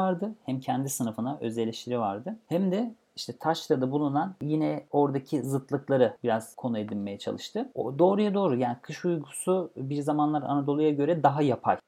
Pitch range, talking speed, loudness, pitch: 125-170 Hz, 155 wpm, -28 LUFS, 145 Hz